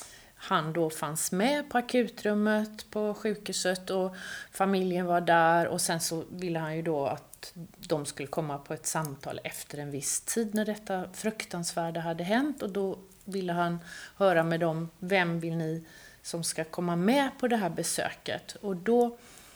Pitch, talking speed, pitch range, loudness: 180 Hz, 170 wpm, 165-210 Hz, -30 LUFS